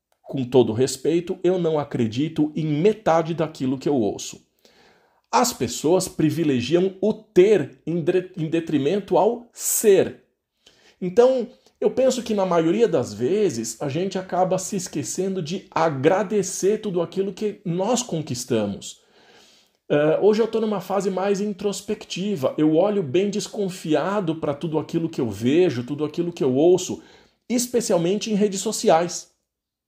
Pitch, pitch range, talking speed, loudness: 180 Hz, 155-205 Hz, 135 wpm, -22 LUFS